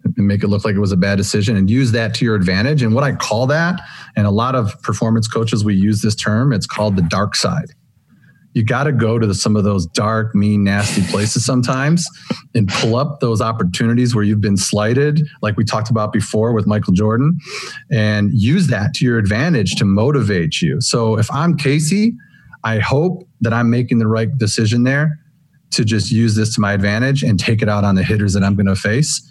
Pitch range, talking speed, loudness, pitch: 105-135 Hz, 220 wpm, -16 LUFS, 115 Hz